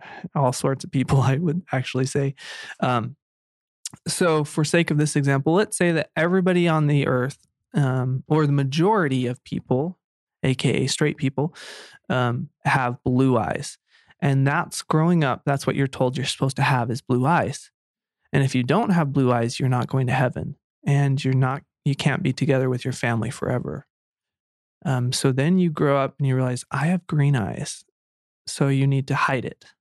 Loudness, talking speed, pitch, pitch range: -22 LUFS, 185 wpm, 140 Hz, 130-155 Hz